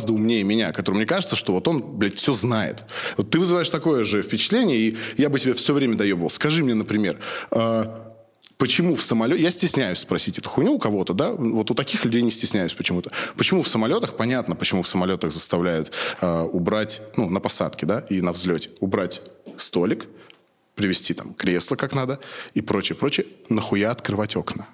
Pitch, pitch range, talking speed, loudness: 110 Hz, 100-130 Hz, 185 wpm, -22 LUFS